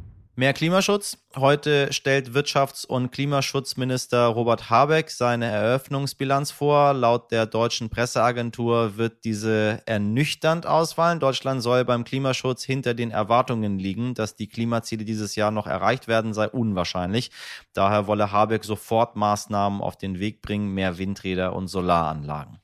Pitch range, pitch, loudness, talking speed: 105-135 Hz, 115 Hz, -23 LUFS, 135 wpm